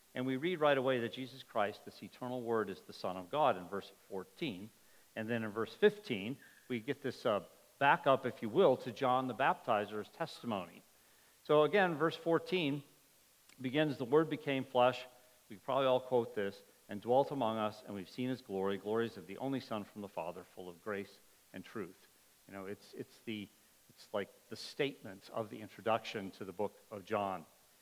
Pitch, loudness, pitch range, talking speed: 125 Hz, -36 LUFS, 105-135 Hz, 195 wpm